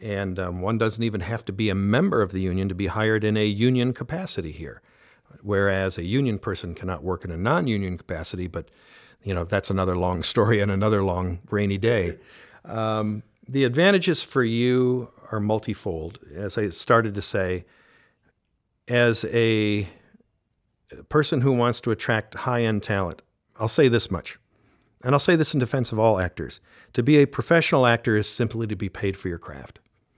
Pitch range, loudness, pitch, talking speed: 95-120 Hz, -24 LUFS, 105 Hz, 180 wpm